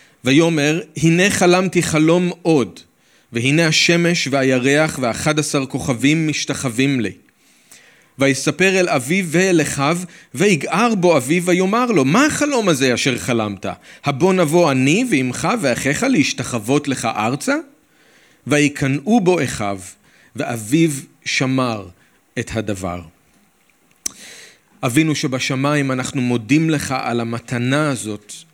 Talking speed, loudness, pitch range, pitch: 105 wpm, -17 LUFS, 130-170 Hz, 145 Hz